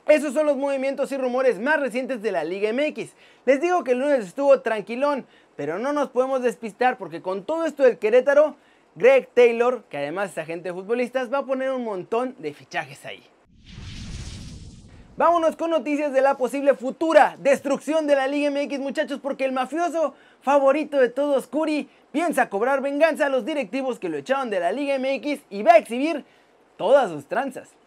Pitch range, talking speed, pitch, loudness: 250-290 Hz, 185 wpm, 275 Hz, -22 LUFS